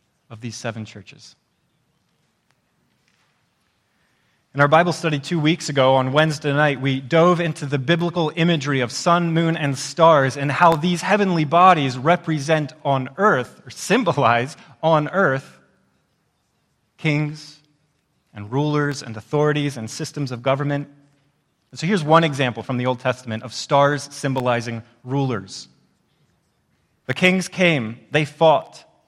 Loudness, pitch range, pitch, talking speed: -19 LUFS, 130-160 Hz, 145 Hz, 130 wpm